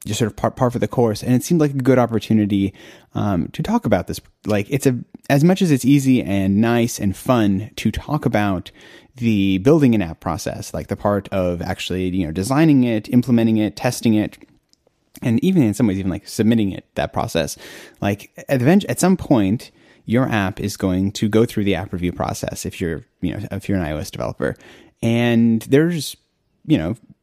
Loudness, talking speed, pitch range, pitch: -19 LUFS, 205 wpm, 100-130 Hz, 110 Hz